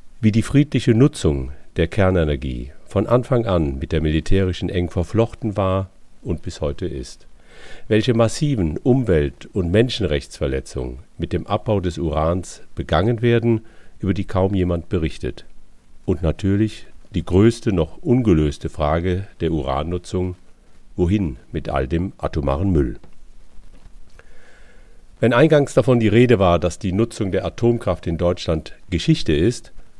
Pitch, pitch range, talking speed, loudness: 90 Hz, 80-110 Hz, 130 wpm, -20 LUFS